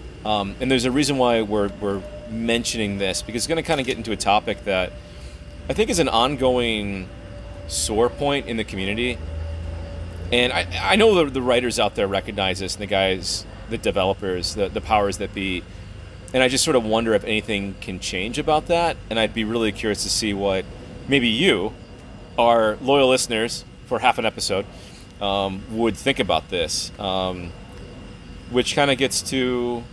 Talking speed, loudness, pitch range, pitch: 180 wpm, -21 LUFS, 95-120 Hz, 105 Hz